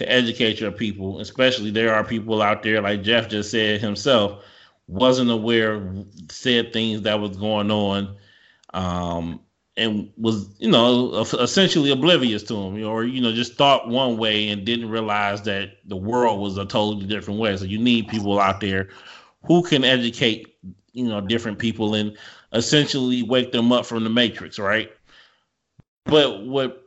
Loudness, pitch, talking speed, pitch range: -21 LUFS, 110 Hz, 165 wpm, 105-120 Hz